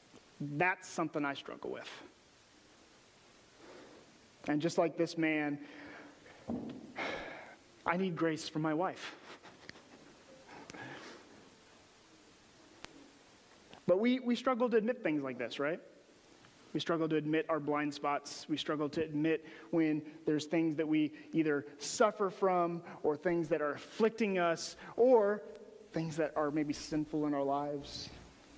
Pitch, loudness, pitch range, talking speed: 160 Hz, -35 LUFS, 150-180 Hz, 125 wpm